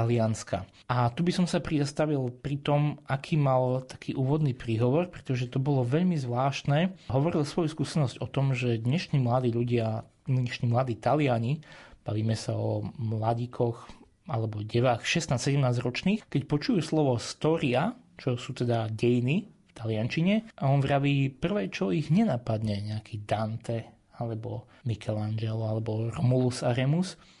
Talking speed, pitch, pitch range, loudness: 135 wpm, 130 Hz, 115-150 Hz, -29 LUFS